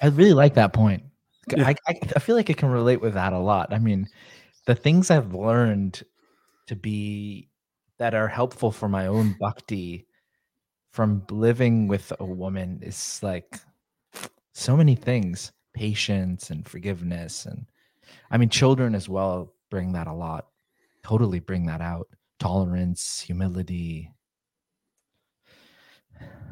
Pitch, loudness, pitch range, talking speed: 105 Hz, -24 LUFS, 95-120 Hz, 135 wpm